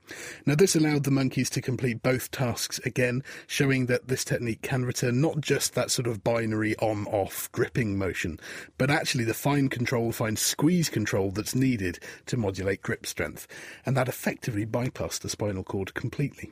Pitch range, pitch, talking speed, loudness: 110-135 Hz, 125 Hz, 175 wpm, -27 LUFS